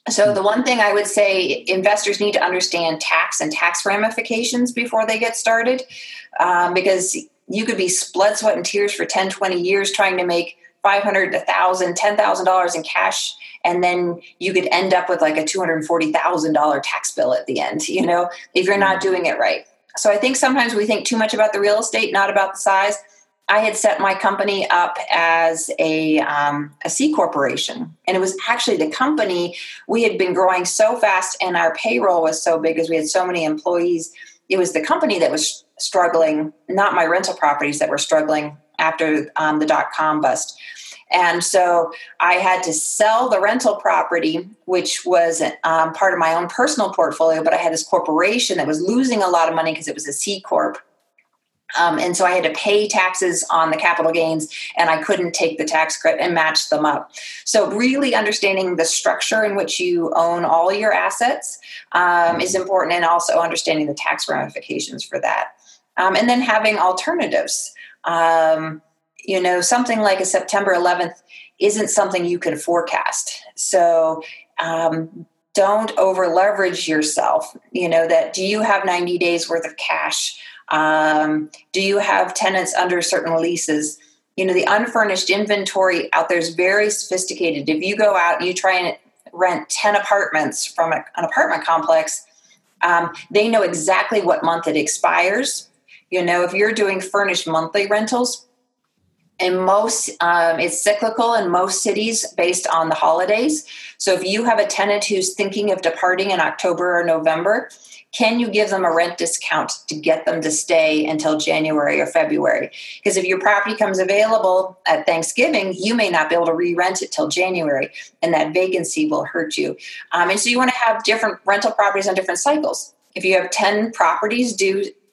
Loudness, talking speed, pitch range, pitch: -18 LUFS, 190 wpm, 165-210 Hz, 185 Hz